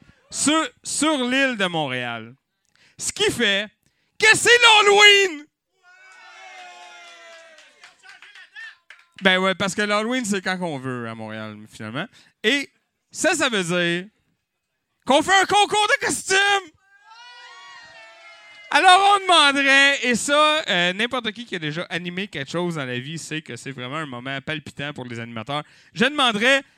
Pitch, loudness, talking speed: 230 Hz, -18 LUFS, 140 wpm